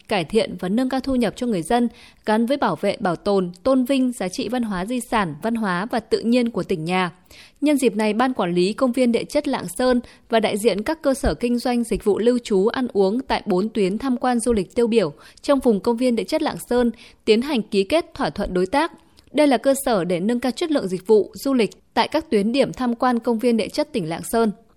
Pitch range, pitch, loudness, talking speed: 200-255 Hz, 235 Hz, -21 LUFS, 265 wpm